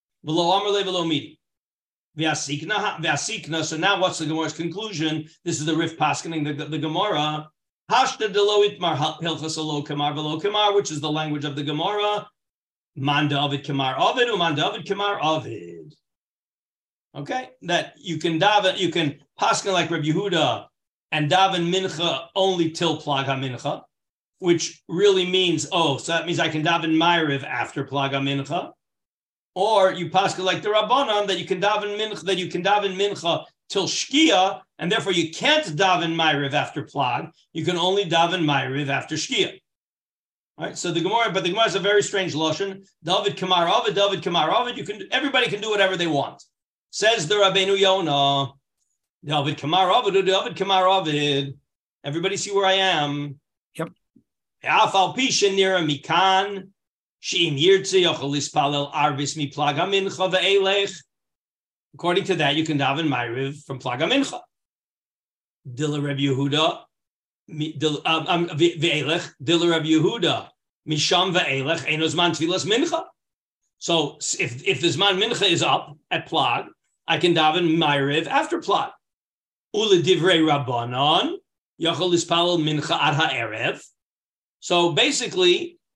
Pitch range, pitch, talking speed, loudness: 150-195 Hz, 170 Hz, 120 wpm, -21 LUFS